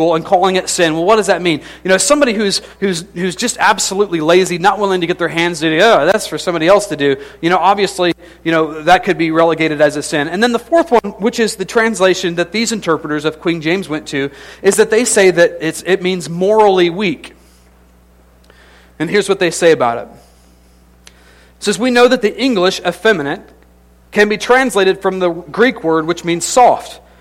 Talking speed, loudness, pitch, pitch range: 210 wpm, -13 LUFS, 175 Hz, 155-200 Hz